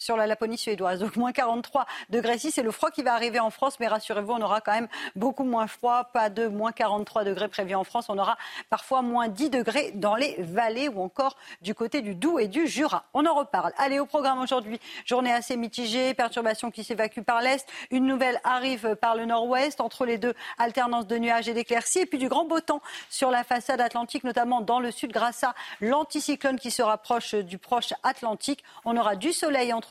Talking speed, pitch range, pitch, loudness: 220 wpm, 225-265 Hz, 240 Hz, -27 LUFS